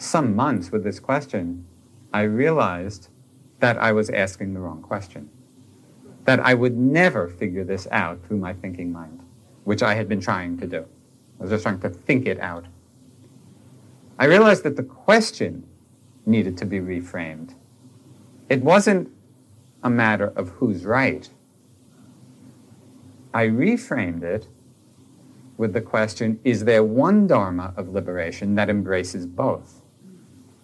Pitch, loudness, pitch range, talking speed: 115 Hz, -21 LUFS, 95-125 Hz, 140 wpm